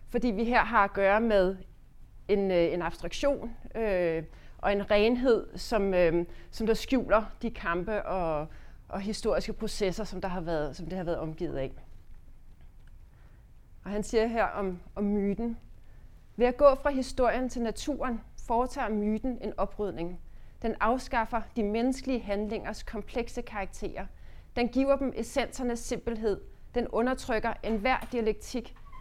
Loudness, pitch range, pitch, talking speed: -30 LUFS, 195-240 Hz, 220 Hz, 145 wpm